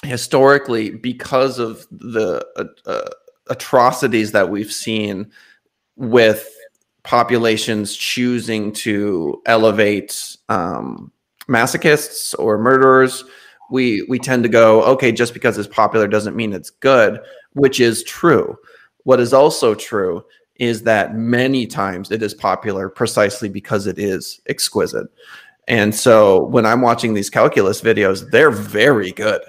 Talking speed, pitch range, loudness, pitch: 130 wpm, 105-130 Hz, -16 LUFS, 115 Hz